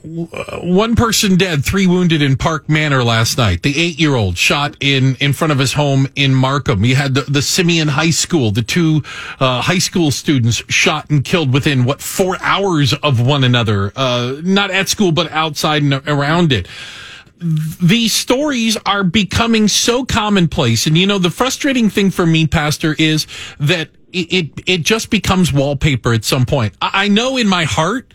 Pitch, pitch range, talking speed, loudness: 155 Hz, 135-185 Hz, 185 wpm, -14 LUFS